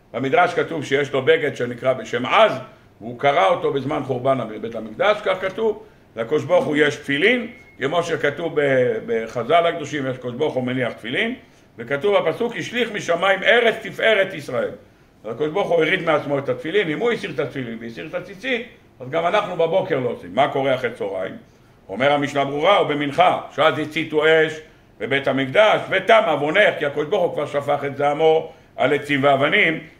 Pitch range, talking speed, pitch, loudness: 135-180 Hz, 165 wpm, 150 Hz, -20 LUFS